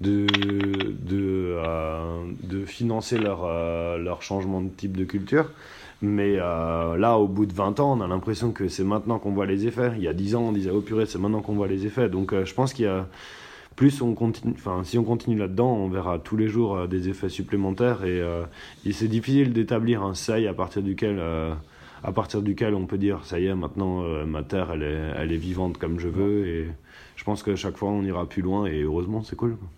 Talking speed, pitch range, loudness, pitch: 240 wpm, 90-110 Hz, -26 LUFS, 100 Hz